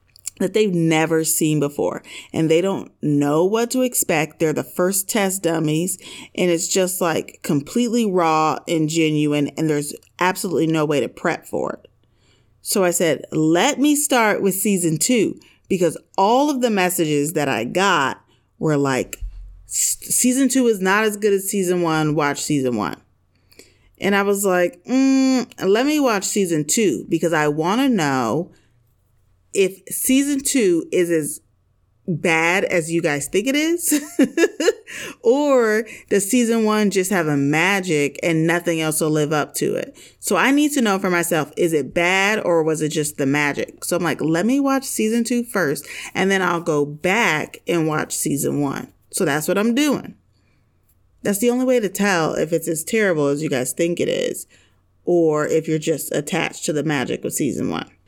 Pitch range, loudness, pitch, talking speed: 150-215 Hz, -19 LUFS, 170 Hz, 180 wpm